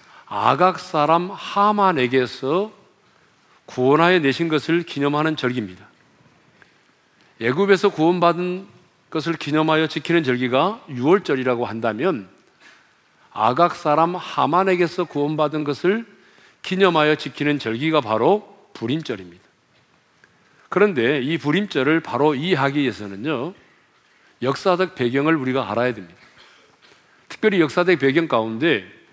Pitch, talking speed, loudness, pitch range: 160 Hz, 275 characters per minute, -20 LUFS, 135-180 Hz